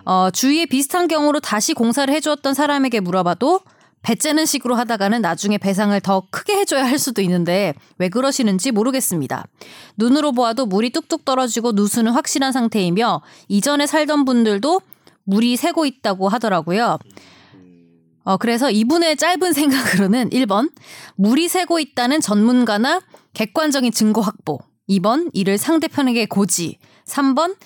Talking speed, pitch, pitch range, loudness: 340 characters per minute, 240 Hz, 200-295 Hz, -18 LUFS